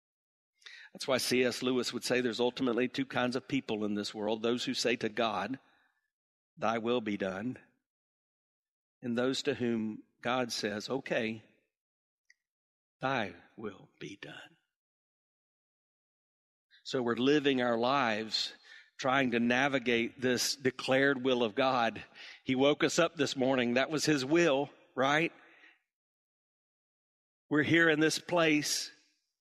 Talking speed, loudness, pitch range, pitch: 130 wpm, -31 LUFS, 120-140 Hz, 125 Hz